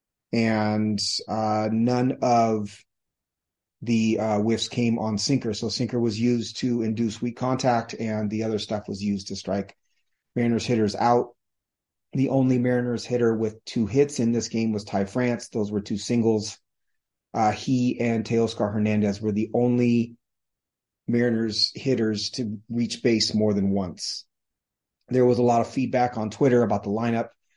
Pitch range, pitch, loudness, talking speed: 105-120 Hz, 115 Hz, -24 LUFS, 160 wpm